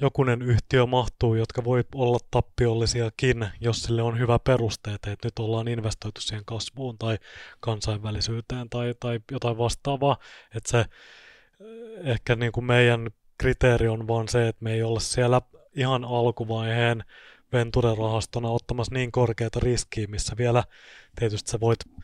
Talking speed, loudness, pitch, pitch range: 140 wpm, -26 LUFS, 120 Hz, 115-125 Hz